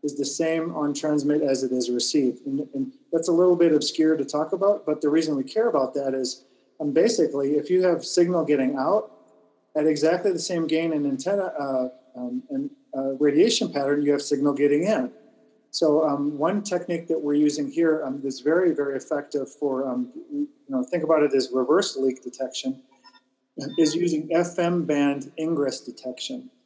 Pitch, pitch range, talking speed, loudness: 150 Hz, 140-170 Hz, 185 wpm, -24 LUFS